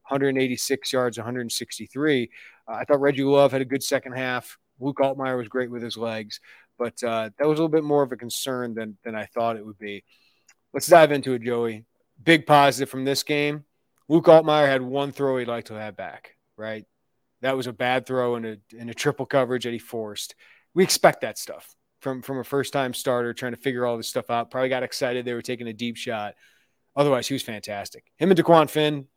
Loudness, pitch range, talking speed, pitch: -23 LUFS, 120-140 Hz, 220 wpm, 130 Hz